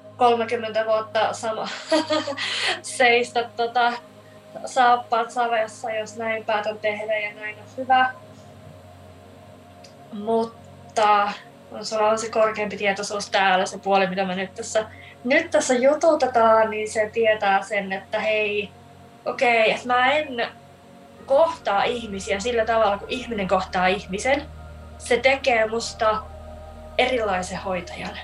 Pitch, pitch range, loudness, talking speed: 220 Hz, 195-240 Hz, -22 LUFS, 115 wpm